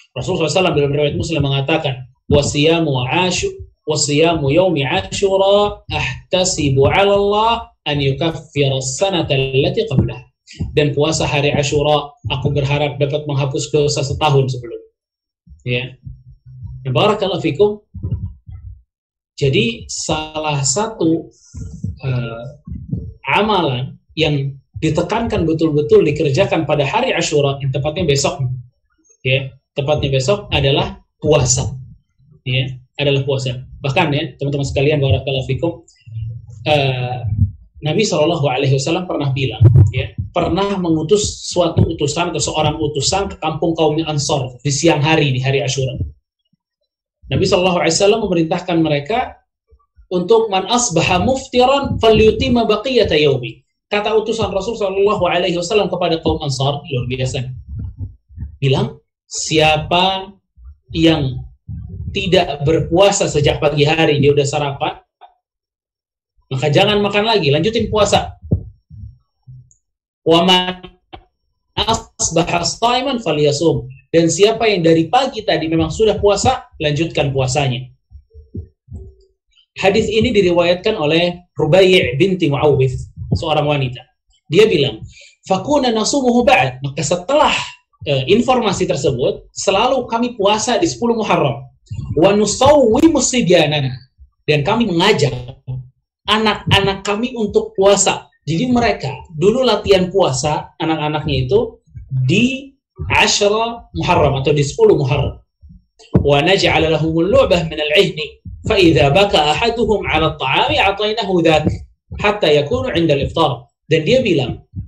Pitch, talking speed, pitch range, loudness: 155 Hz, 100 wpm, 135-195 Hz, -15 LUFS